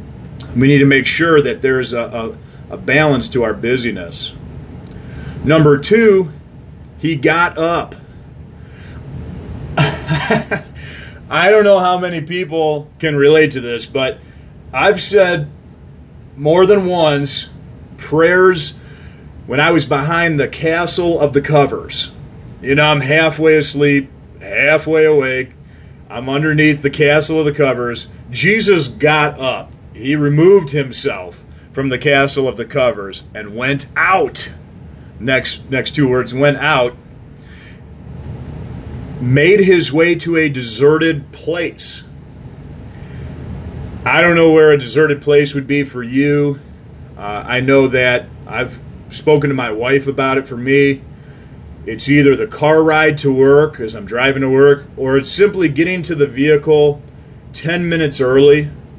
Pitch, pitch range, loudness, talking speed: 145 Hz, 135-160 Hz, -13 LUFS, 135 wpm